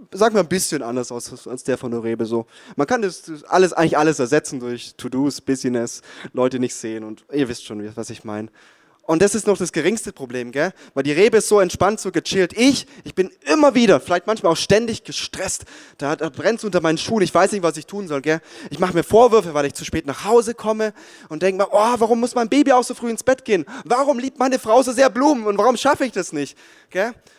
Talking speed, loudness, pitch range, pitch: 250 wpm, -19 LUFS, 135-225 Hz, 180 Hz